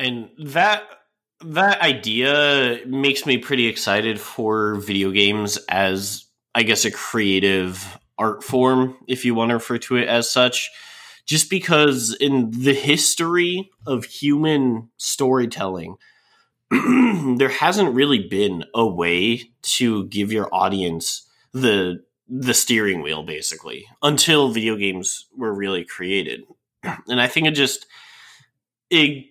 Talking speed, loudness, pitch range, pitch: 125 wpm, -19 LUFS, 110-145 Hz, 125 Hz